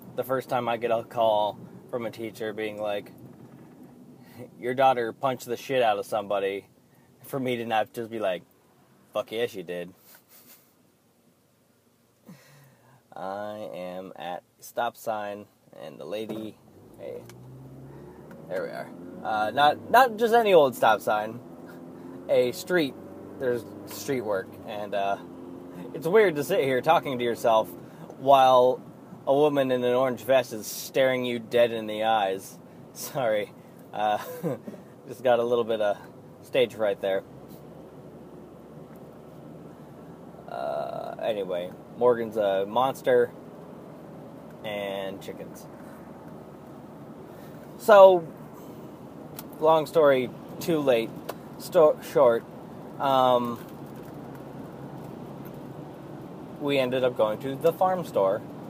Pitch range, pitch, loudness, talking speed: 100-135 Hz, 120 Hz, -25 LUFS, 115 wpm